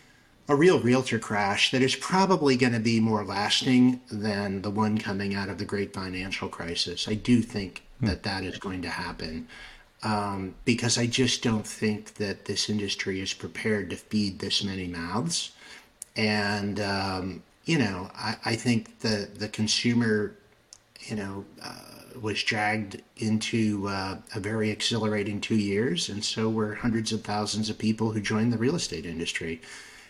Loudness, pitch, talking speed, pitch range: -27 LUFS, 105 Hz, 165 wpm, 100-115 Hz